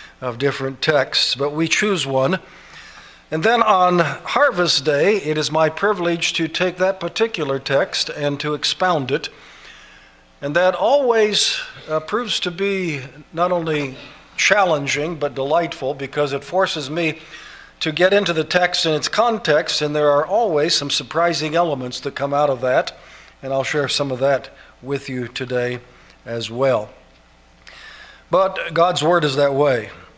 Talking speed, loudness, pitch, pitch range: 155 wpm, -19 LUFS, 150 Hz, 135-175 Hz